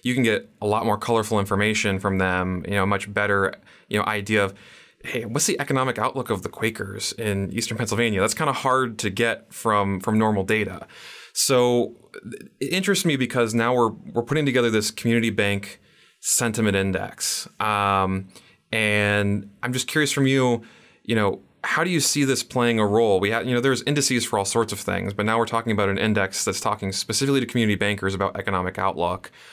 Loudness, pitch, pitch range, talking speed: -23 LUFS, 110 Hz, 100-125 Hz, 200 wpm